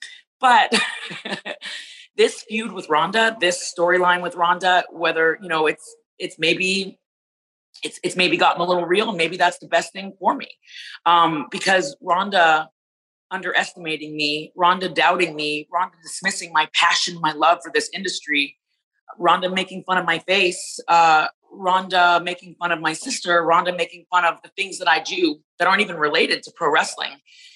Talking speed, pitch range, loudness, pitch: 165 wpm, 165-190 Hz, -19 LUFS, 175 Hz